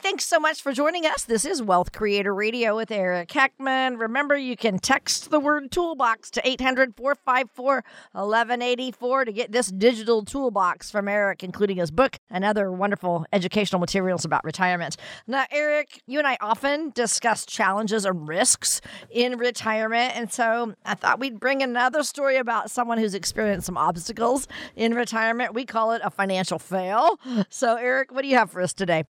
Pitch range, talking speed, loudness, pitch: 200-265 Hz, 175 wpm, -23 LUFS, 230 Hz